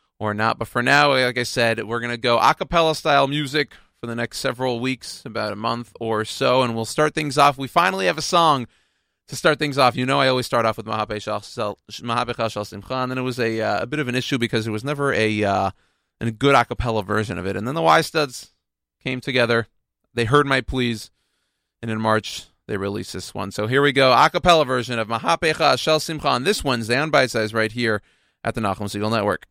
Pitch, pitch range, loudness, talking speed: 120 Hz, 110-140 Hz, -21 LUFS, 225 wpm